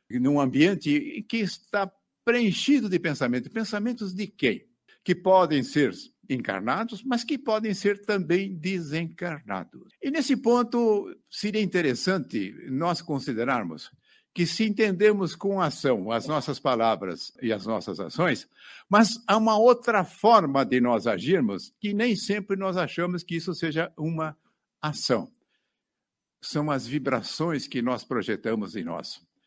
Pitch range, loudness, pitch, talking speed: 150-215 Hz, -26 LUFS, 190 Hz, 130 wpm